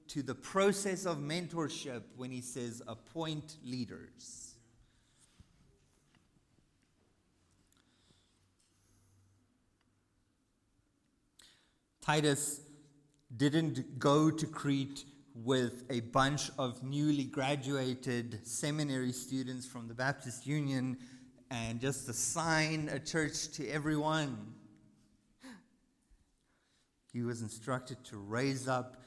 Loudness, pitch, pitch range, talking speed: -36 LUFS, 130 Hz, 120-145 Hz, 85 wpm